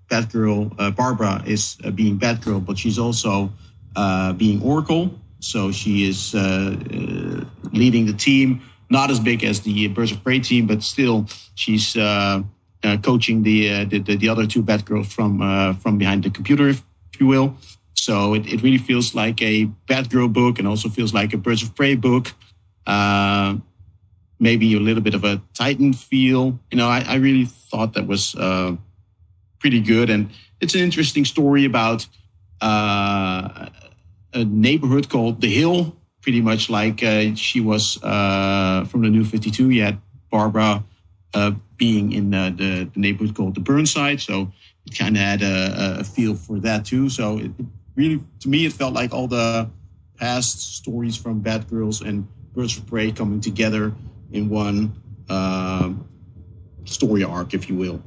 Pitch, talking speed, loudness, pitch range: 110 Hz, 175 wpm, -19 LUFS, 100-120 Hz